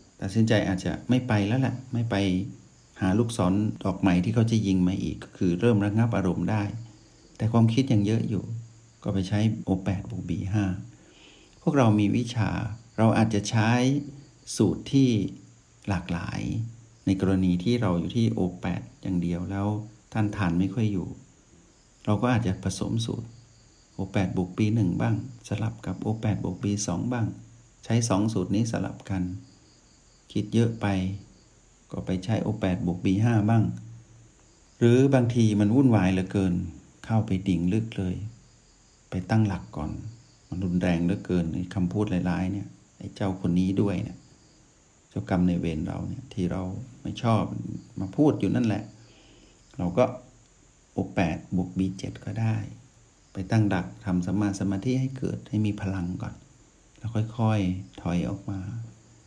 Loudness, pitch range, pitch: -27 LUFS, 95-115 Hz, 105 Hz